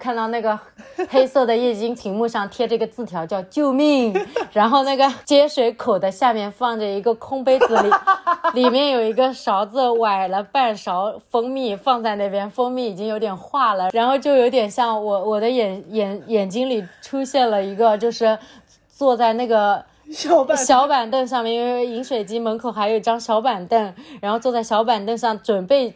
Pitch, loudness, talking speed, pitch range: 235 Hz, -19 LUFS, 275 characters per minute, 215-260 Hz